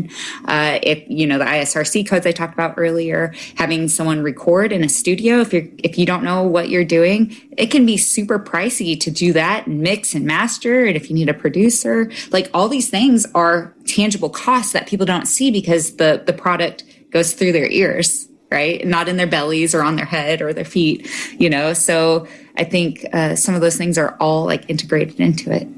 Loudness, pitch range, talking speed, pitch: -16 LUFS, 160-210 Hz, 210 wpm, 175 Hz